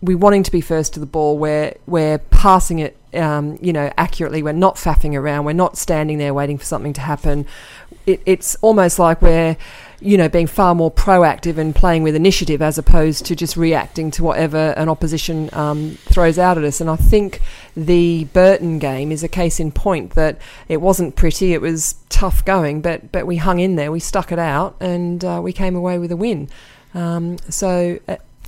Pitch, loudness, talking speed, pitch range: 165 Hz, -17 LUFS, 210 wpm, 155-180 Hz